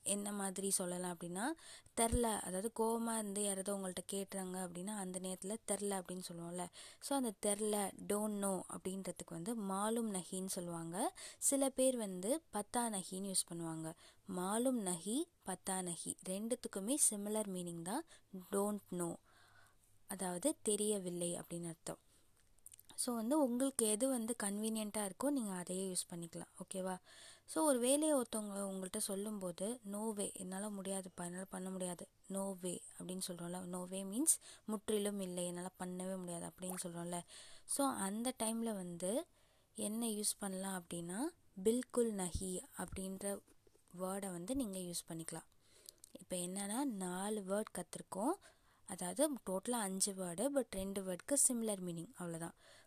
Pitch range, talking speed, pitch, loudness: 180-225 Hz, 130 wpm, 195 Hz, -40 LUFS